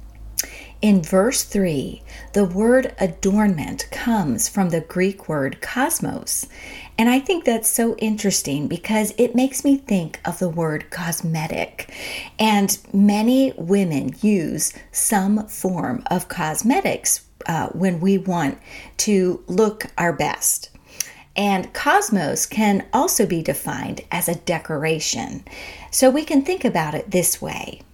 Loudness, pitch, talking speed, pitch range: -20 LUFS, 195 Hz, 130 wpm, 170-220 Hz